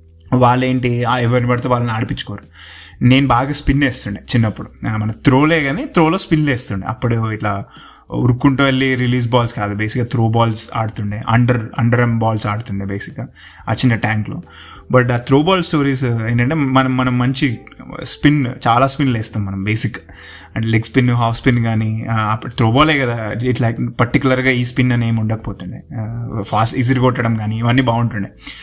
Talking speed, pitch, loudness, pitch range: 150 wpm, 120 Hz, -16 LUFS, 110-130 Hz